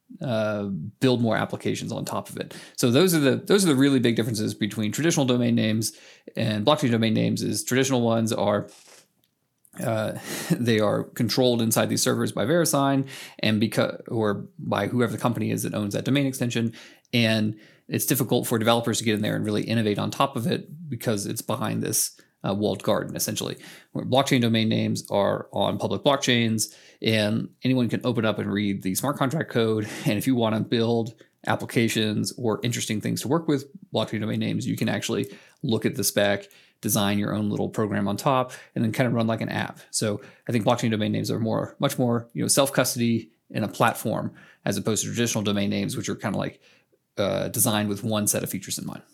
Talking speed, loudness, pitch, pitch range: 205 wpm, -25 LUFS, 115 Hz, 110-130 Hz